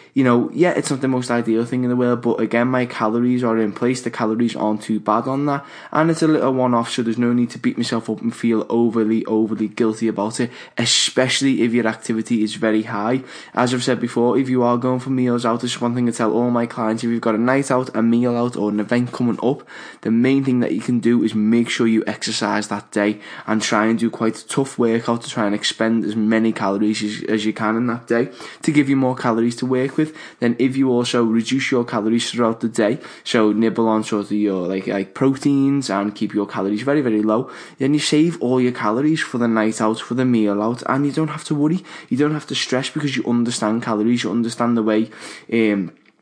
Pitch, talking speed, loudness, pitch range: 115 Hz, 250 wpm, -19 LUFS, 110-125 Hz